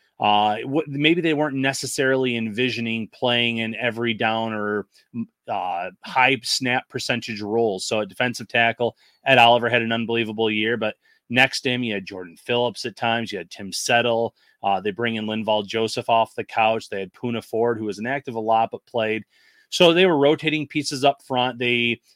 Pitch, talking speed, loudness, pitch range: 120 Hz, 185 wpm, -22 LUFS, 110-130 Hz